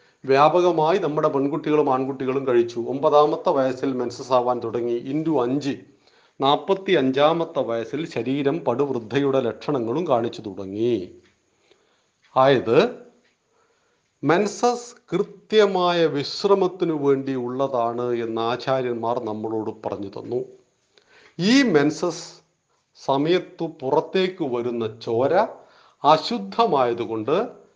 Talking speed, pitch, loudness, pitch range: 80 wpm, 145 Hz, -22 LUFS, 125-185 Hz